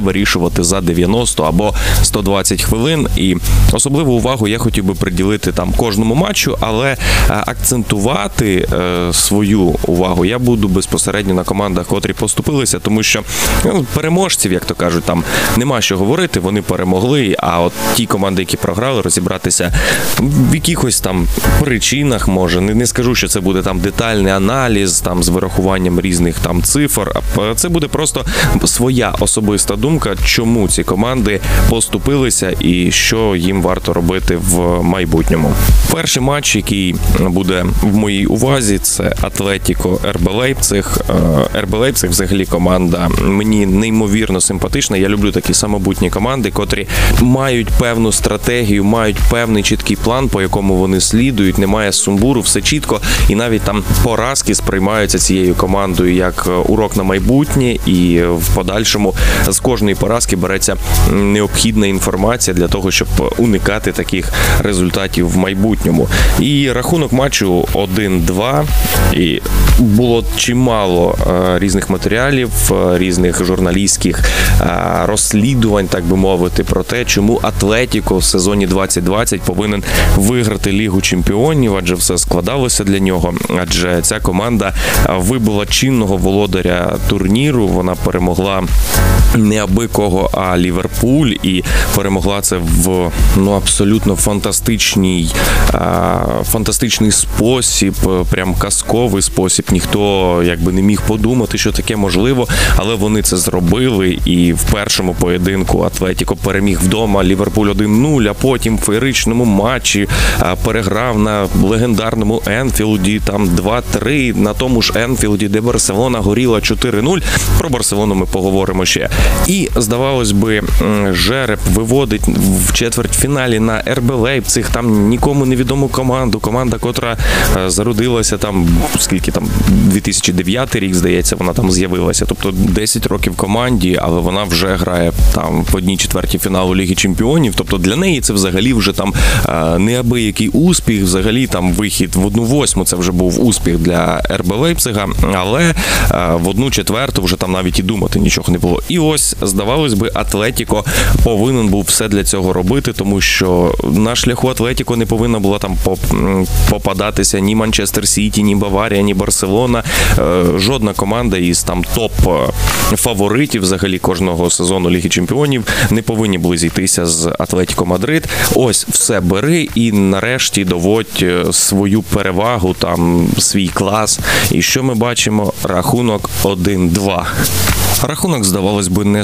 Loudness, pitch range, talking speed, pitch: -12 LUFS, 90-115 Hz, 130 wpm, 100 Hz